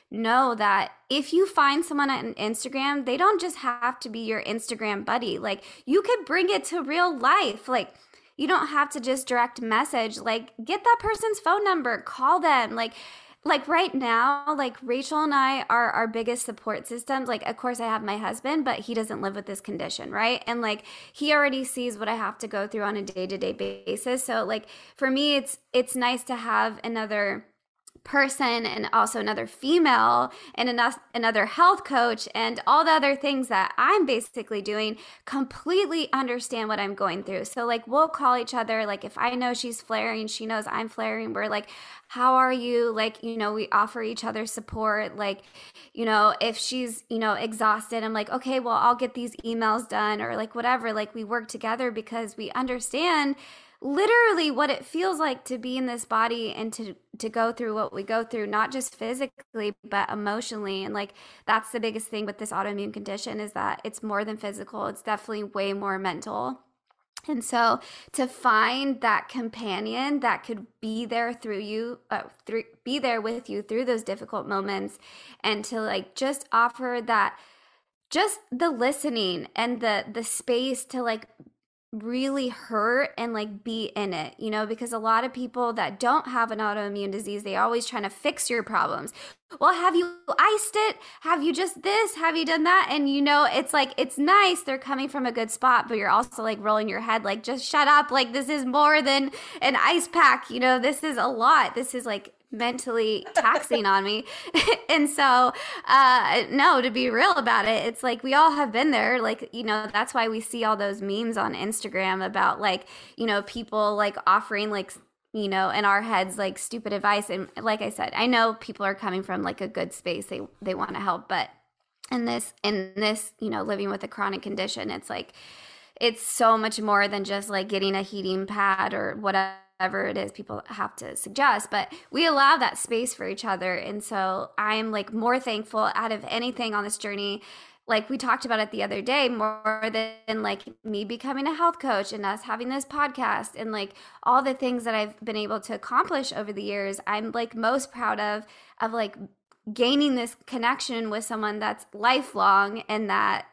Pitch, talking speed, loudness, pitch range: 230 Hz, 200 wpm, -25 LUFS, 215-265 Hz